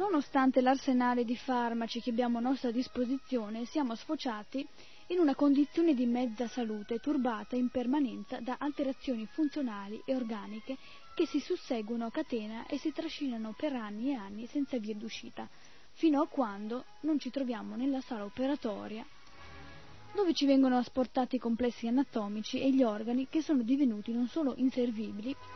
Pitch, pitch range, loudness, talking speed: 255 Hz, 235-280 Hz, -33 LUFS, 155 wpm